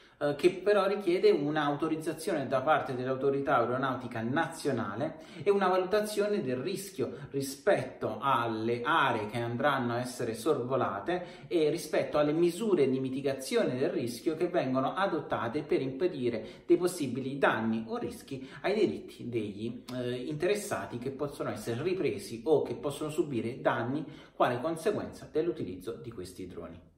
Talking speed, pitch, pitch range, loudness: 130 wpm, 140 Hz, 125-175 Hz, -31 LUFS